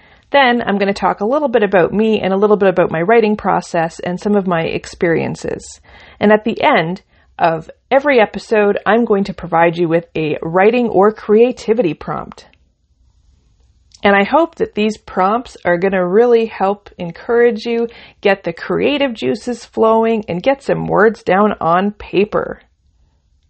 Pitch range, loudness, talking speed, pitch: 170-230 Hz, -15 LUFS, 170 wpm, 200 Hz